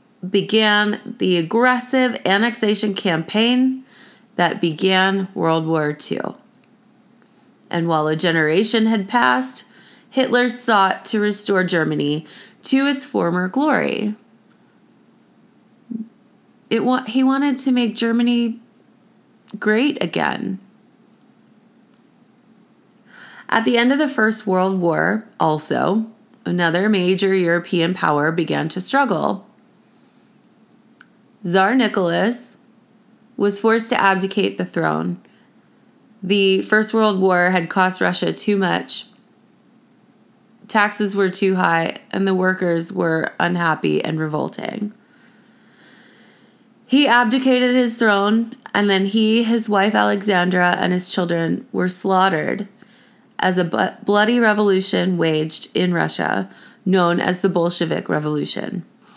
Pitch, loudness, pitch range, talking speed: 215 Hz, -18 LUFS, 185-235 Hz, 105 wpm